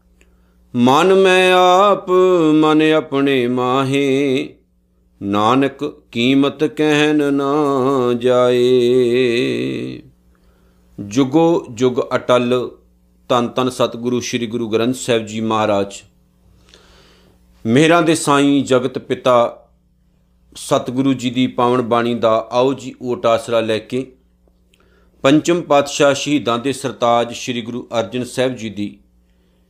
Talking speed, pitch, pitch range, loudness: 100 wpm, 125 Hz, 110-140 Hz, -16 LUFS